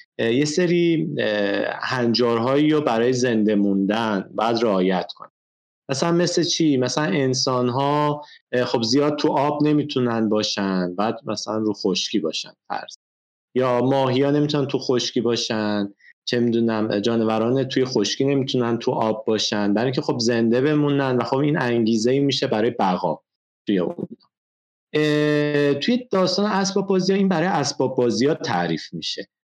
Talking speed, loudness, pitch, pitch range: 140 wpm, -21 LUFS, 130 Hz, 110-150 Hz